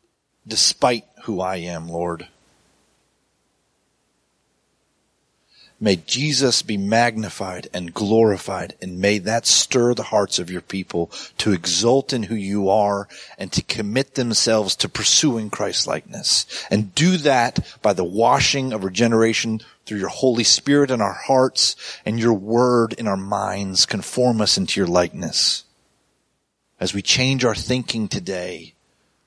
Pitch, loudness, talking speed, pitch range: 110 Hz, -19 LUFS, 135 wpm, 95-120 Hz